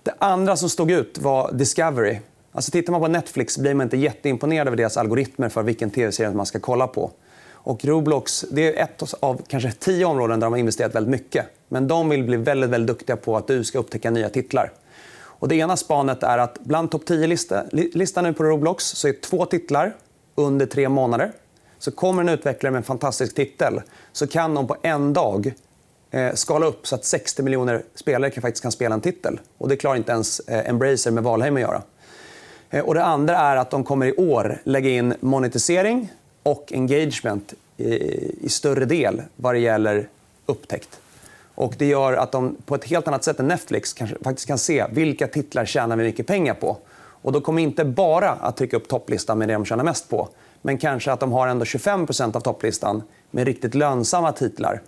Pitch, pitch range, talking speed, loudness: 135 Hz, 120-155 Hz, 200 wpm, -22 LUFS